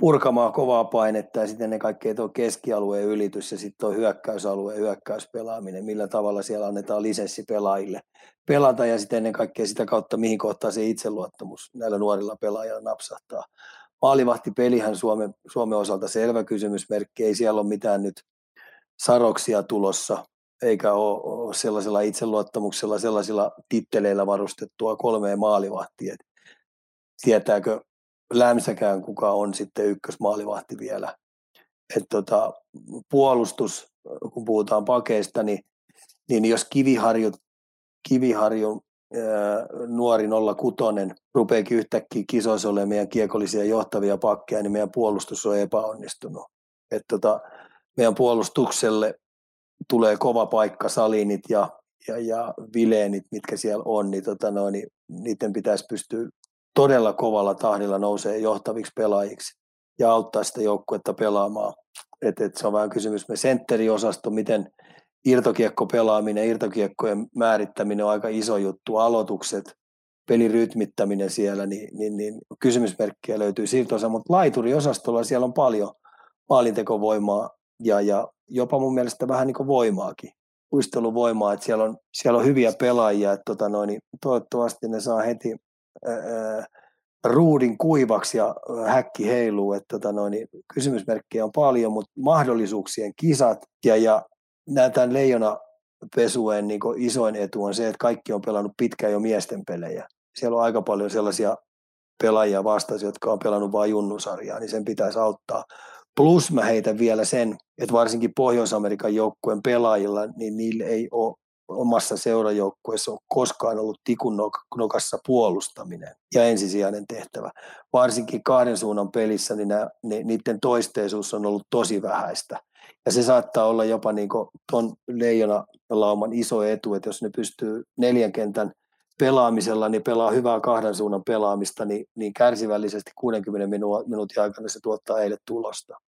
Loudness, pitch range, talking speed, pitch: -23 LUFS, 105-115 Hz, 135 wpm, 110 Hz